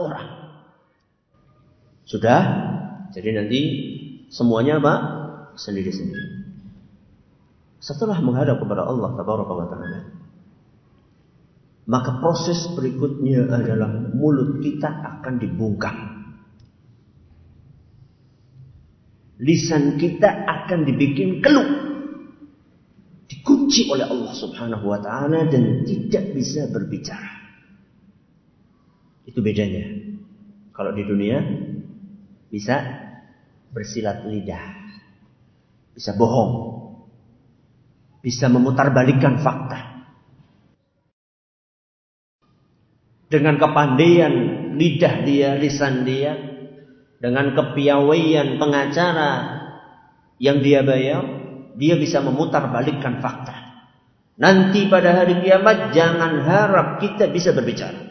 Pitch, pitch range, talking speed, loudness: 140 Hz, 125-165 Hz, 75 wpm, -19 LUFS